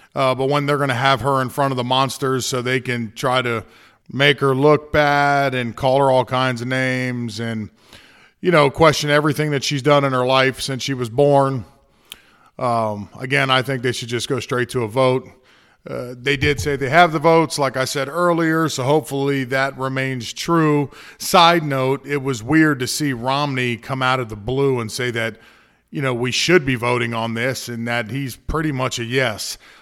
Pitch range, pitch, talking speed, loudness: 125-145 Hz, 130 Hz, 210 wpm, -18 LUFS